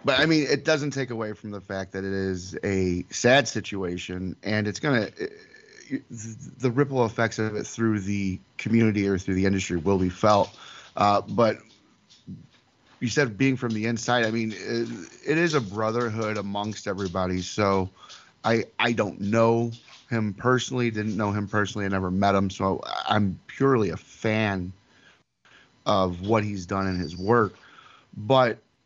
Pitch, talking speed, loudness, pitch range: 105 Hz, 170 wpm, -25 LUFS, 95-120 Hz